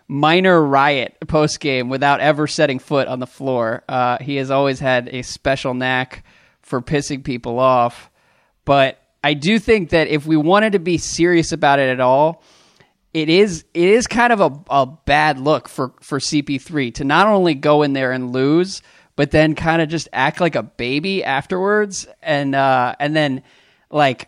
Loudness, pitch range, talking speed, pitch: -17 LUFS, 130-160 Hz, 185 wpm, 145 Hz